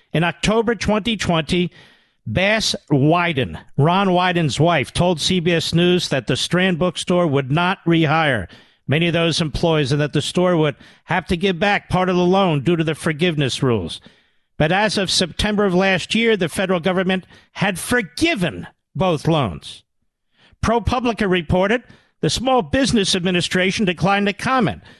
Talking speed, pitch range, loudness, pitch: 150 wpm, 160-195 Hz, -18 LUFS, 180 Hz